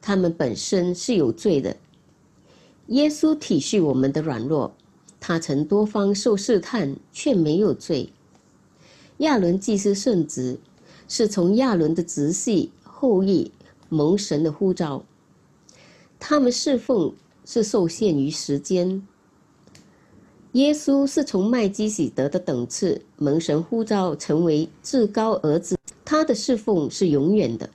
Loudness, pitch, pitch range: -22 LUFS, 190 Hz, 155-235 Hz